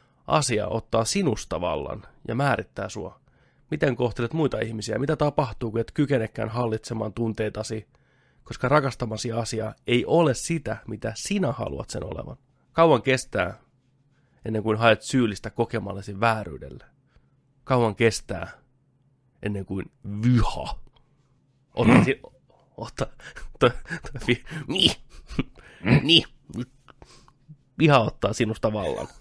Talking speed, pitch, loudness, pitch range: 90 wpm, 120 Hz, -25 LUFS, 110-135 Hz